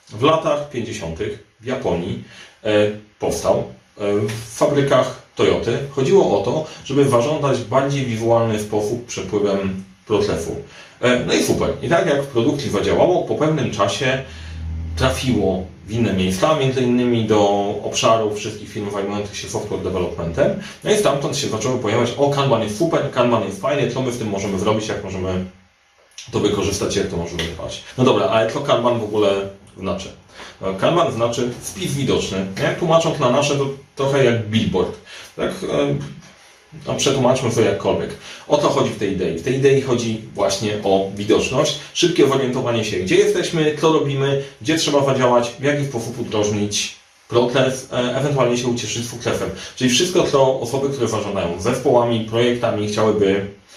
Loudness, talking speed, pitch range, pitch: -19 LUFS, 155 wpm, 100-135 Hz, 115 Hz